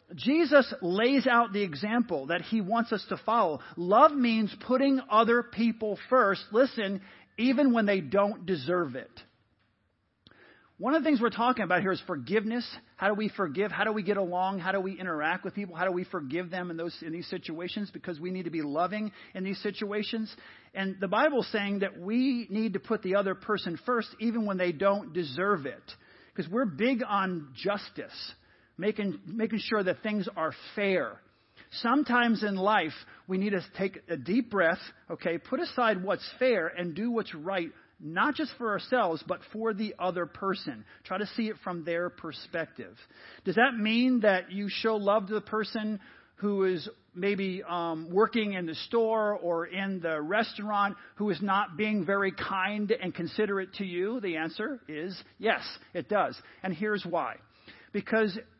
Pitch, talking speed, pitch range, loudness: 200 Hz, 180 wpm, 180-225 Hz, -29 LUFS